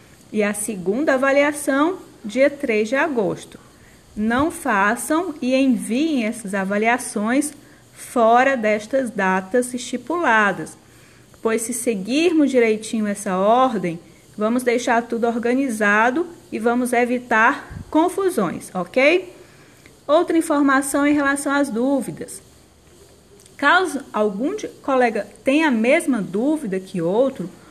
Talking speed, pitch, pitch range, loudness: 105 wpm, 245 Hz, 215-285 Hz, -19 LUFS